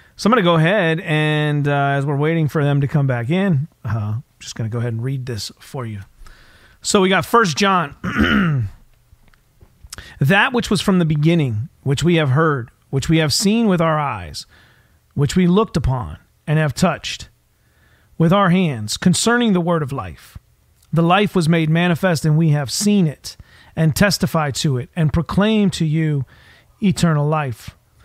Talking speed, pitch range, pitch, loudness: 185 wpm, 135-180 Hz, 155 Hz, -17 LUFS